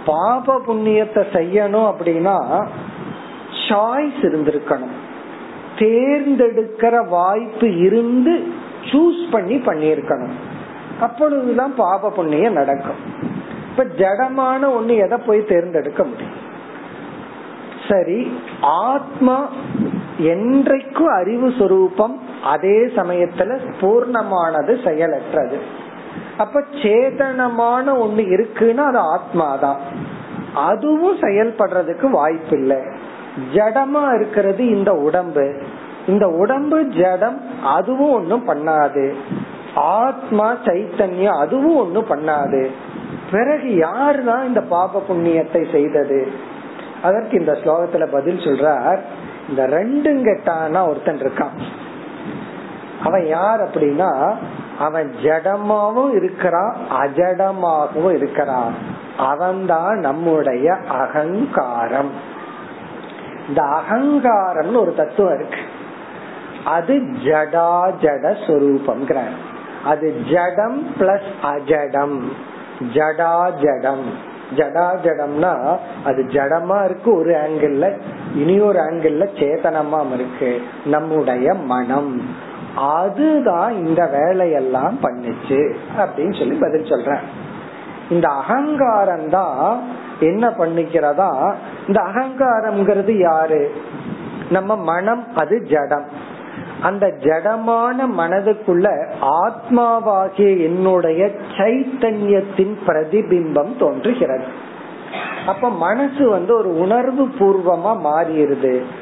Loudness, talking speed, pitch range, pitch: -17 LUFS, 70 wpm, 160-235 Hz, 195 Hz